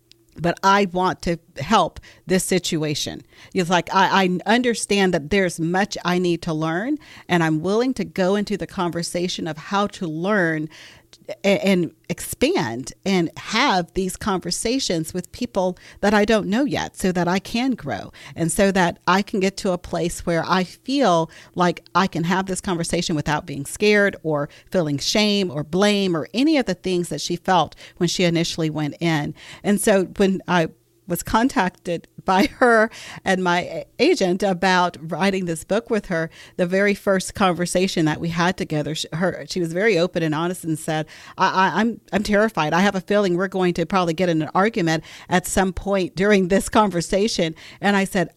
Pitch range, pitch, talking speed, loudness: 165-195 Hz, 180 Hz, 185 wpm, -21 LUFS